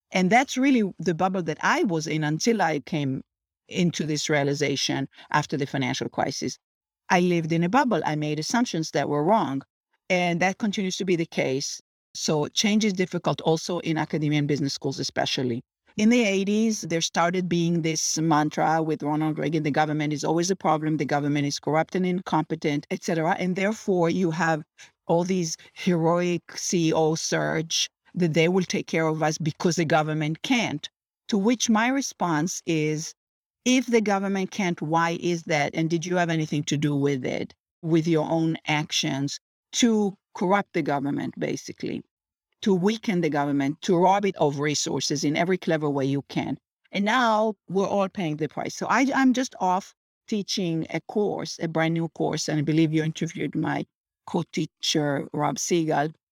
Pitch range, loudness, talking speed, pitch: 155-190 Hz, -25 LUFS, 180 wpm, 165 Hz